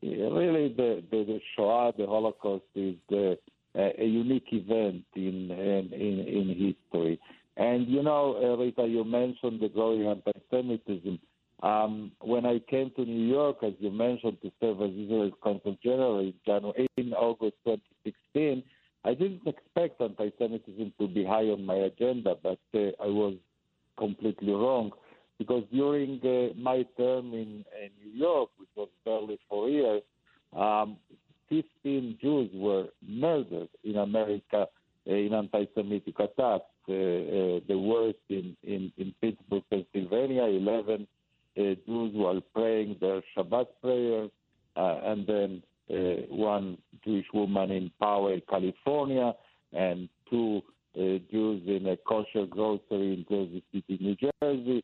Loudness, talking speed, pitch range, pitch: -30 LUFS, 140 wpm, 100-120 Hz, 105 Hz